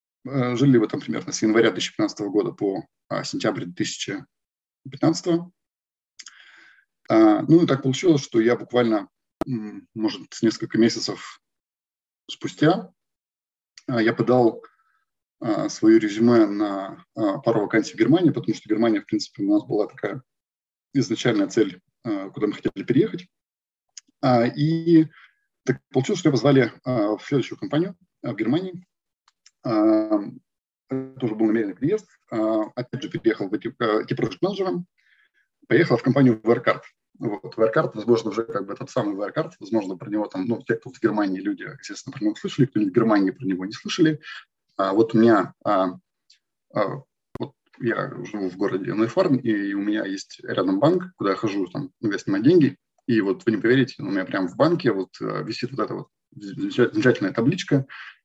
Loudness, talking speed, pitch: -23 LUFS, 150 wpm, 135 Hz